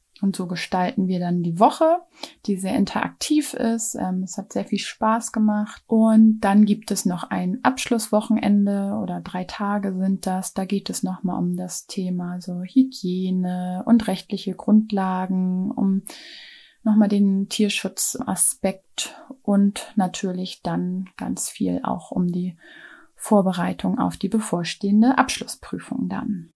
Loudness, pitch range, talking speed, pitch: -22 LUFS, 185-220 Hz, 135 wpm, 200 Hz